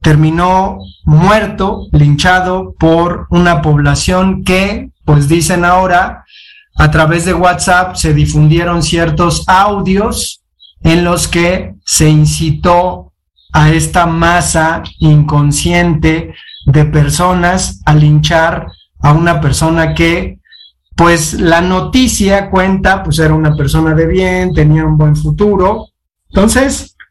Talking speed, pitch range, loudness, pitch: 110 wpm, 155-185 Hz, -10 LUFS, 170 Hz